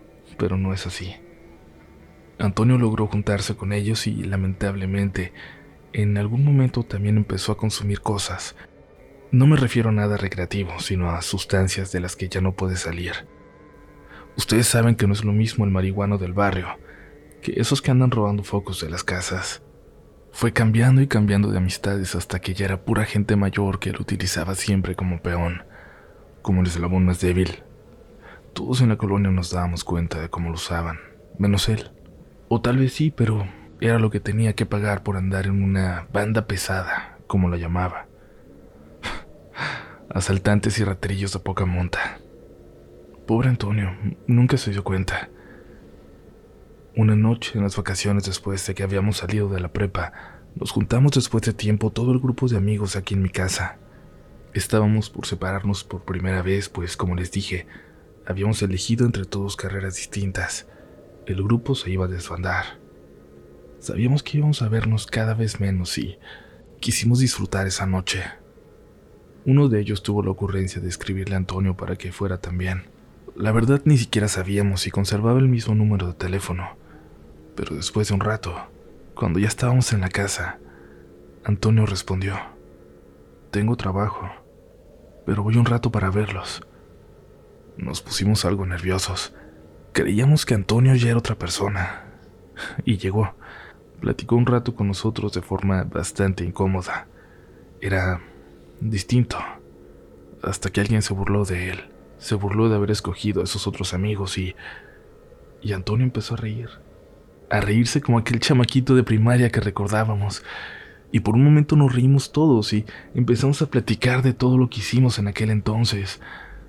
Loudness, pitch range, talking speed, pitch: -22 LUFS, 95-110 Hz, 160 wpm, 100 Hz